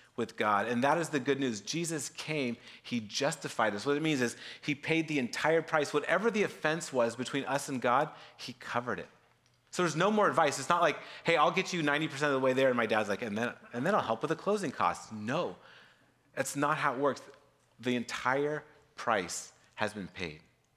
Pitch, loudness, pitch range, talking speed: 145 Hz, -32 LUFS, 120-155 Hz, 220 wpm